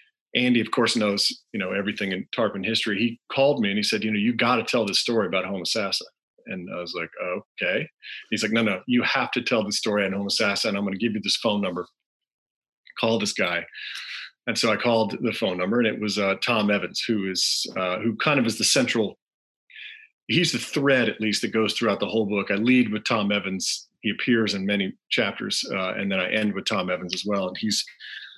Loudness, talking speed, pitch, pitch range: -24 LUFS, 235 wpm, 110 Hz, 100-120 Hz